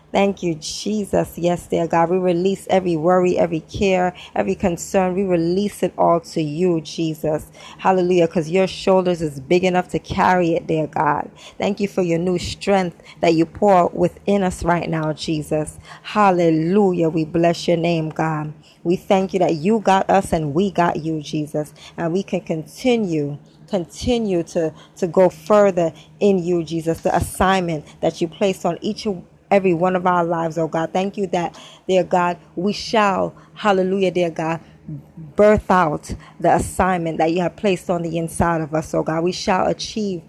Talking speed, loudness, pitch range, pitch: 180 wpm, -19 LUFS, 165-190 Hz, 175 Hz